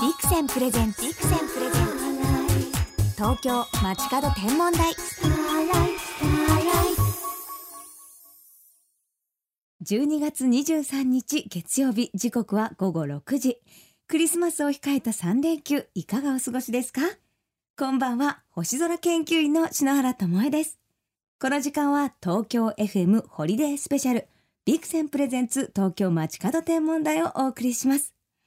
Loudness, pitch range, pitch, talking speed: -25 LUFS, 225-310 Hz, 270 Hz, 255 characters per minute